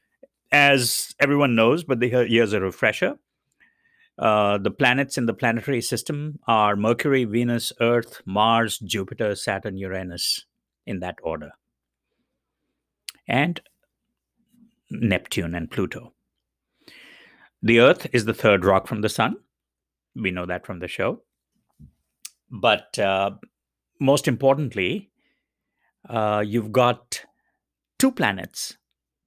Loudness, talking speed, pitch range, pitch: -22 LUFS, 110 wpm, 100-140 Hz, 115 Hz